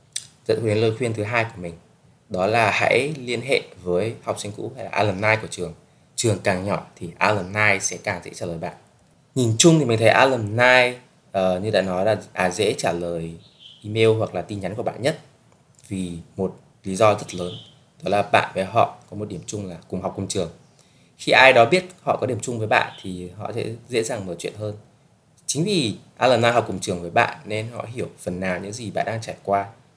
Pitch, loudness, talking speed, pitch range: 110 Hz, -21 LUFS, 225 wpm, 95-120 Hz